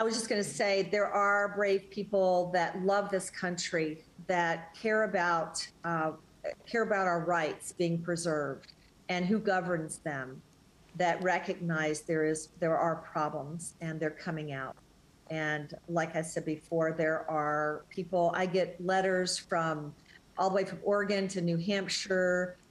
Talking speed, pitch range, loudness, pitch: 155 wpm, 160-190 Hz, -32 LUFS, 175 Hz